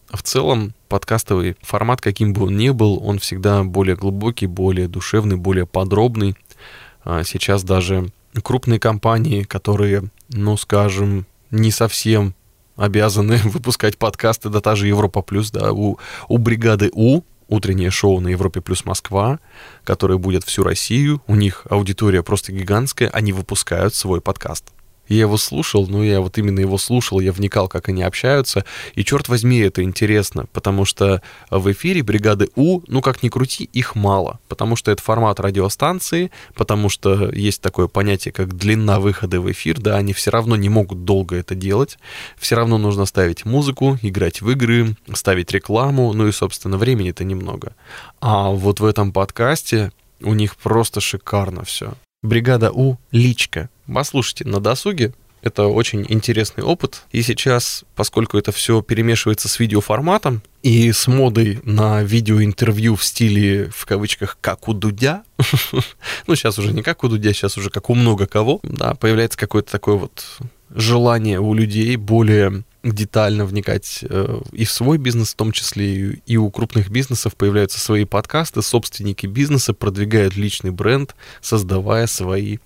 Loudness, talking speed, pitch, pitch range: -18 LUFS, 155 wpm, 105 Hz, 100-115 Hz